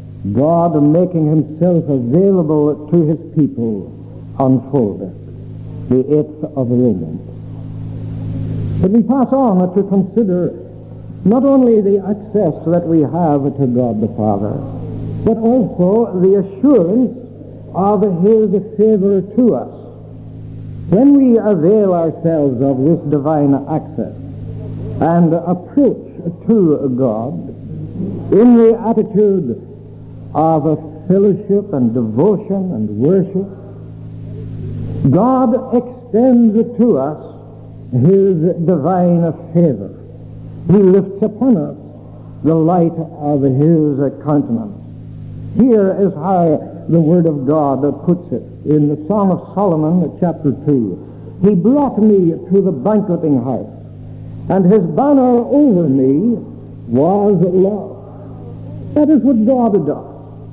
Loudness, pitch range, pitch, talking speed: -14 LUFS, 130-200 Hz, 160 Hz, 110 wpm